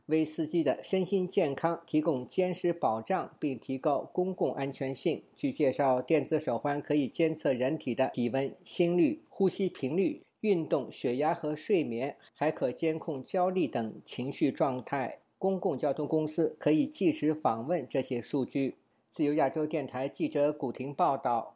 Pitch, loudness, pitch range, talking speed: 155 Hz, -31 LUFS, 135-175 Hz, 250 characters per minute